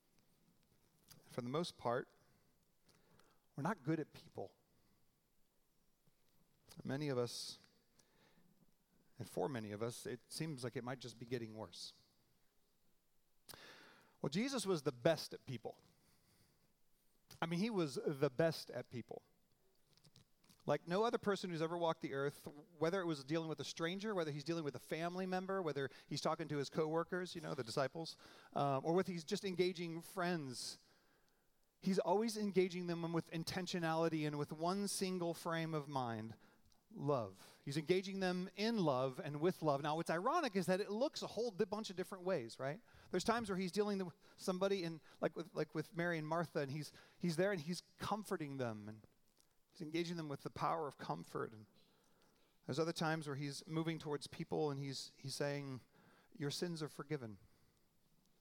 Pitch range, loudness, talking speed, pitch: 145-185 Hz, -42 LUFS, 175 wpm, 165 Hz